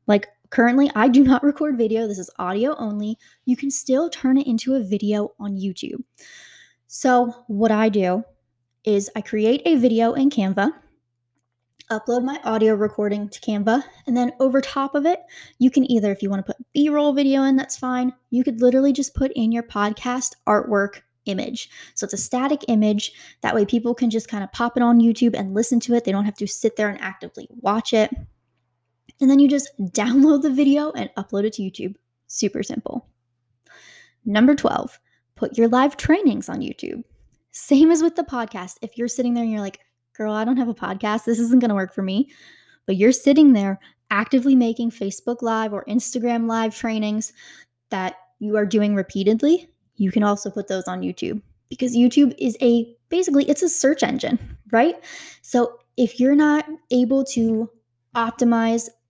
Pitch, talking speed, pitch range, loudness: 230 Hz, 185 wpm, 205-265 Hz, -20 LUFS